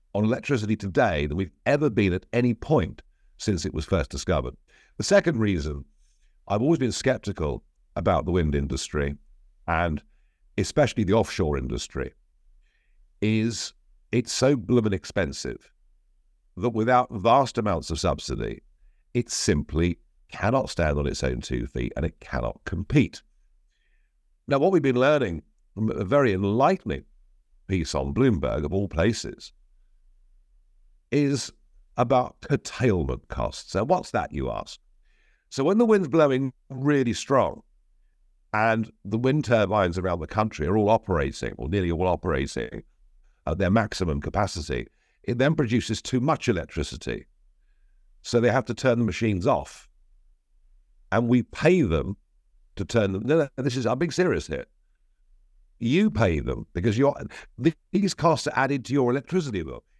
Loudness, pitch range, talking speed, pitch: -25 LUFS, 75-125 Hz, 145 wpm, 100 Hz